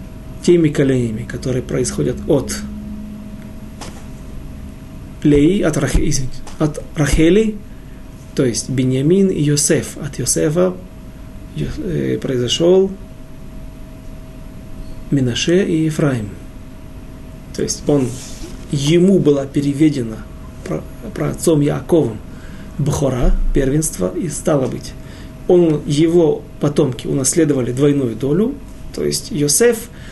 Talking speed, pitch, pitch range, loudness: 90 wpm, 145 Hz, 125-165 Hz, -16 LUFS